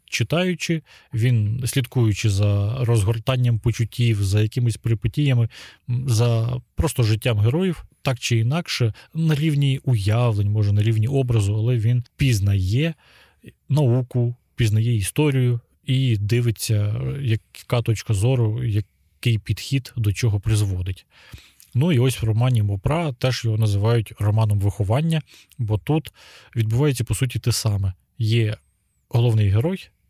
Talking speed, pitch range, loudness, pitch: 120 wpm, 110-130 Hz, -22 LUFS, 115 Hz